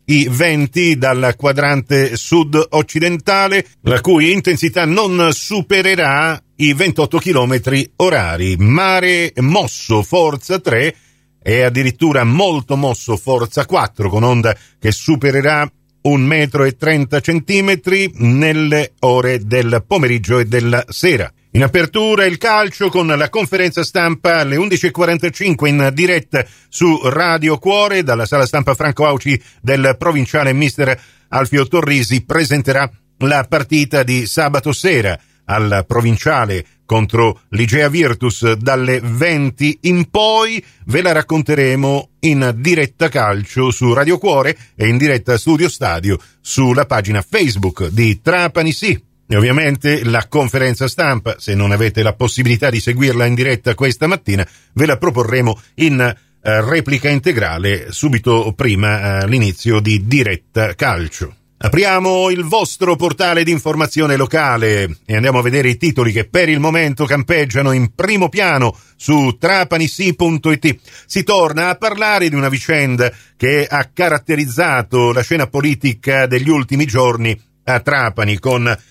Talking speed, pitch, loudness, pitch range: 130 wpm, 140 Hz, -14 LUFS, 120-165 Hz